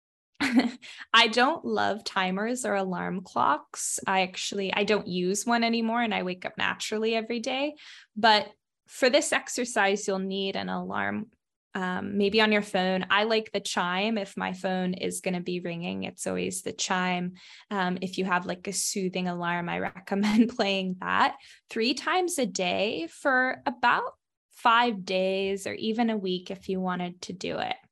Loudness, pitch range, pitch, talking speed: -27 LUFS, 185-230 Hz, 195 Hz, 170 wpm